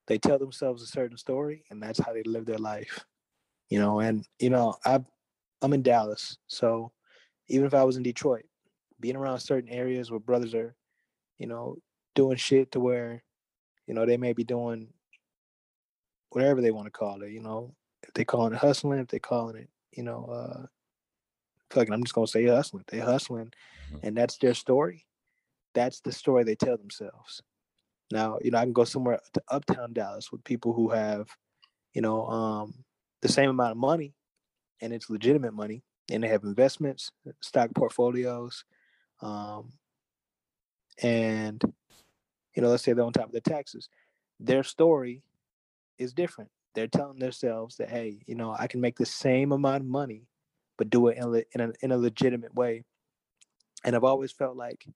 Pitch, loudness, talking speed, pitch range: 120 Hz, -28 LUFS, 180 wpm, 115-130 Hz